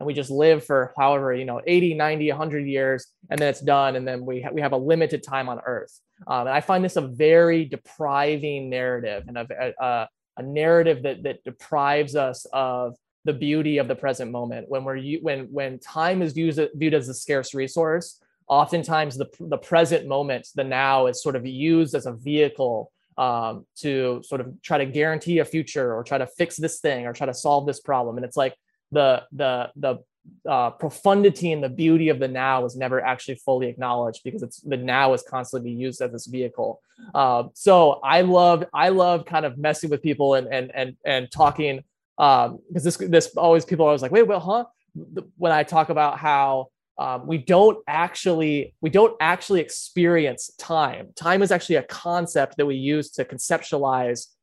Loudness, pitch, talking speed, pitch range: -22 LUFS, 145 Hz, 200 wpm, 130-165 Hz